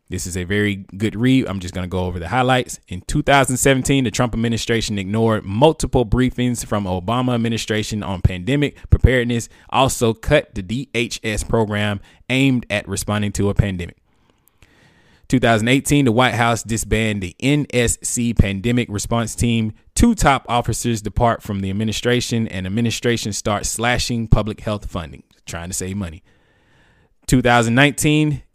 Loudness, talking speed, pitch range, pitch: -19 LUFS, 145 wpm, 100-125 Hz, 115 Hz